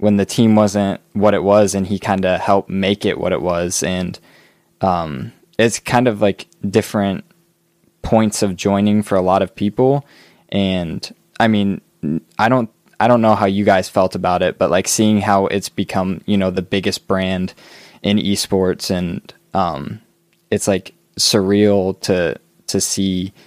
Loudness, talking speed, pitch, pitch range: -17 LUFS, 170 wpm, 100 Hz, 95-105 Hz